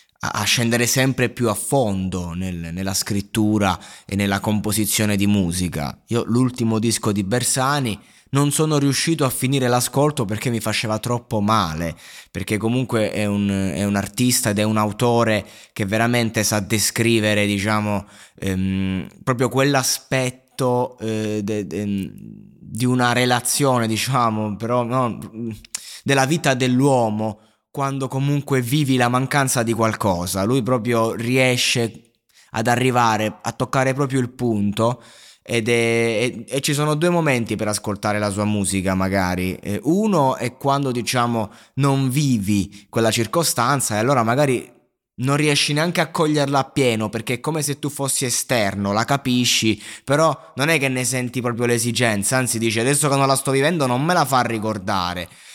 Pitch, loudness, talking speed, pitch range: 115 Hz, -20 LUFS, 150 wpm, 105-130 Hz